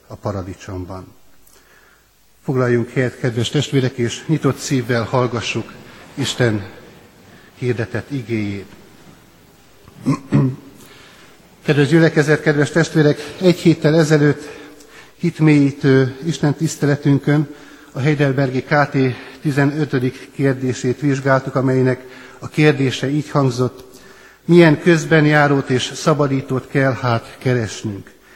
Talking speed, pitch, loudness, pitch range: 90 wpm, 135 Hz, -17 LUFS, 125-150 Hz